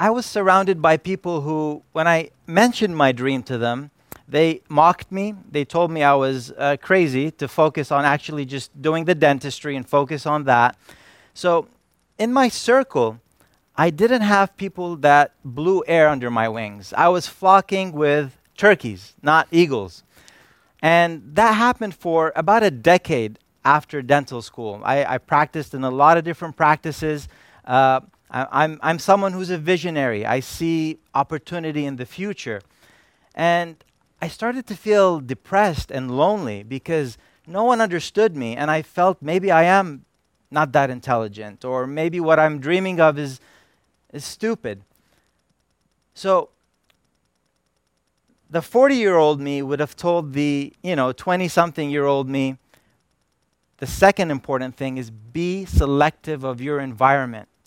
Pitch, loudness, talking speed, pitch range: 155 Hz, -19 LUFS, 150 wpm, 135-175 Hz